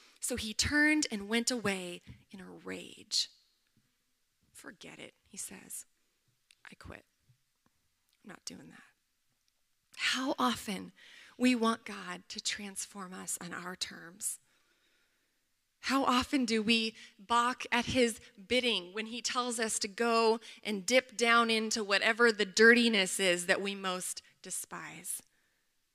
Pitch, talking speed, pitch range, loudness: 225 Hz, 130 wpm, 195-240 Hz, -31 LUFS